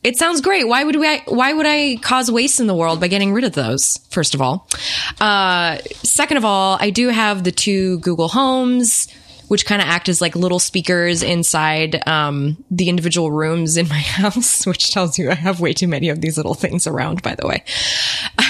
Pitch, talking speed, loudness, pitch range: 180 Hz, 215 wpm, -16 LUFS, 165-230 Hz